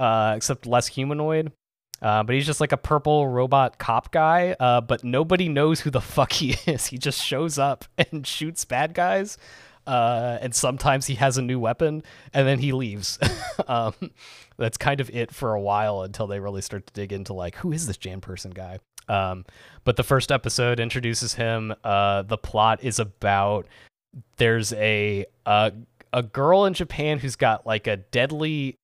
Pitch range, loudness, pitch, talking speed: 105-140 Hz, -23 LUFS, 125 Hz, 185 wpm